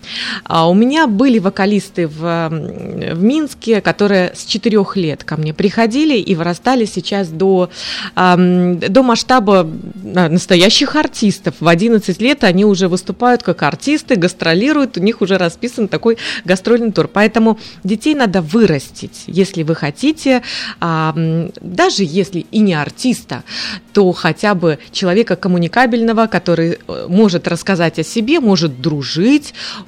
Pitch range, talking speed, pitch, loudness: 175-230 Hz, 125 wpm, 195 Hz, -14 LUFS